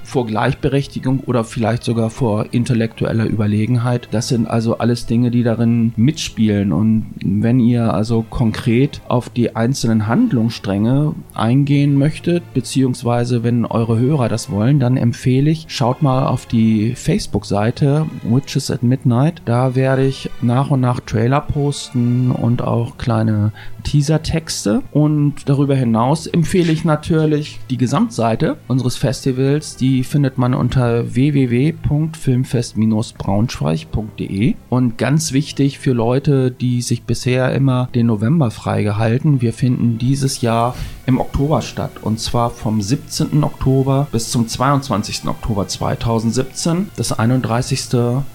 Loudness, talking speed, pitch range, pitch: -17 LUFS, 130 wpm, 115-140 Hz, 125 Hz